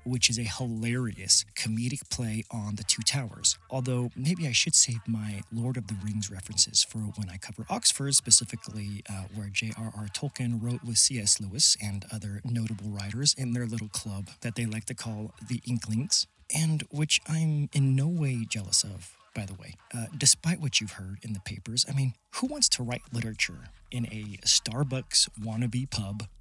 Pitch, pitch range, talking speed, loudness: 115 Hz, 105-125 Hz, 185 wpm, -27 LUFS